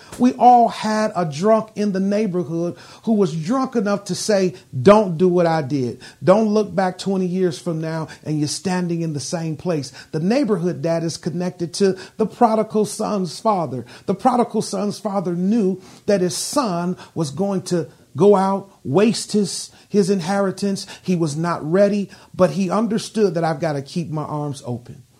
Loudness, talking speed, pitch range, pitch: -20 LUFS, 180 wpm, 165-205 Hz, 185 Hz